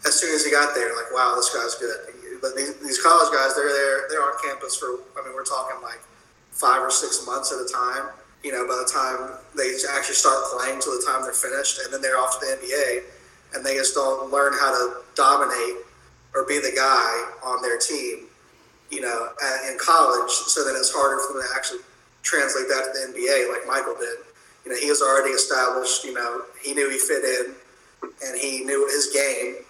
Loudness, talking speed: -22 LUFS, 220 wpm